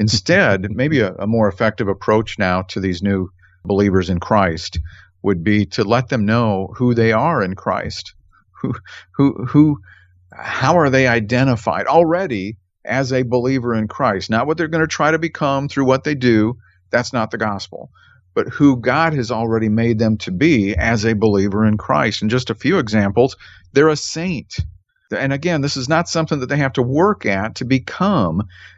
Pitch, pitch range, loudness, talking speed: 115 Hz, 100-135 Hz, -17 LUFS, 190 wpm